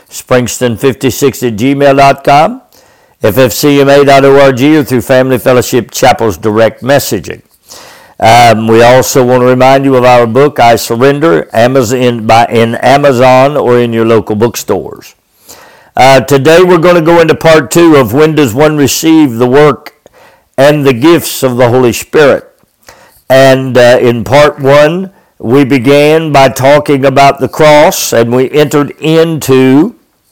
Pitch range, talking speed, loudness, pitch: 125-145 Hz, 140 wpm, -6 LUFS, 135 Hz